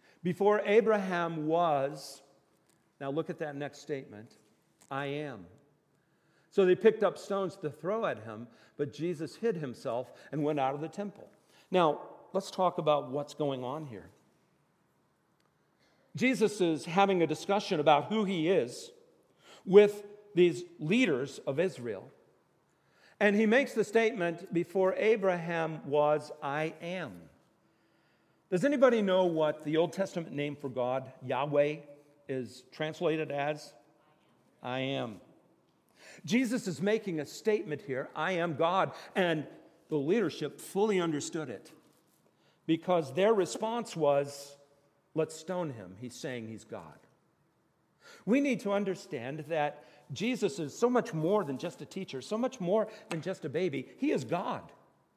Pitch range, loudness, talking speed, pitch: 145-195 Hz, -31 LUFS, 140 wpm, 165 Hz